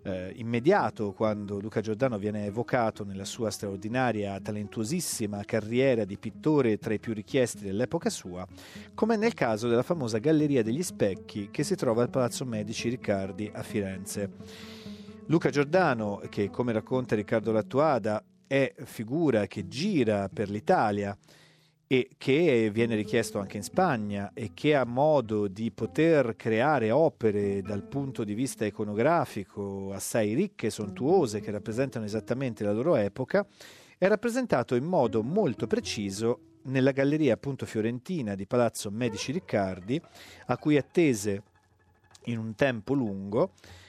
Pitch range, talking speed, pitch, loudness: 105-135 Hz, 135 wpm, 110 Hz, -28 LUFS